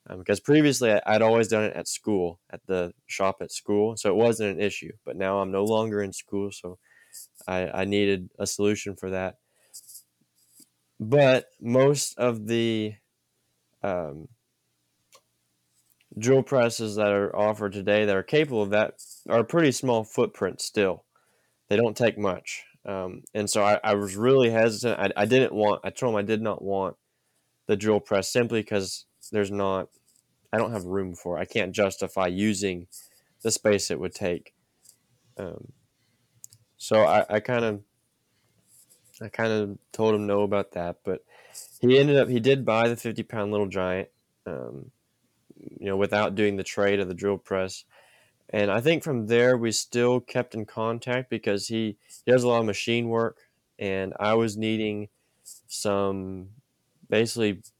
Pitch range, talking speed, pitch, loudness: 95-115 Hz, 165 wpm, 105 Hz, -25 LUFS